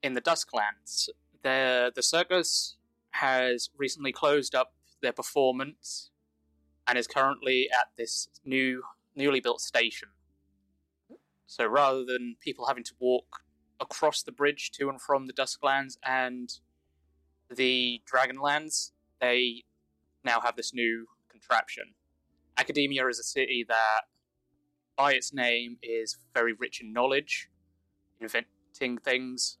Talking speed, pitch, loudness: 120 wpm, 120 Hz, -29 LUFS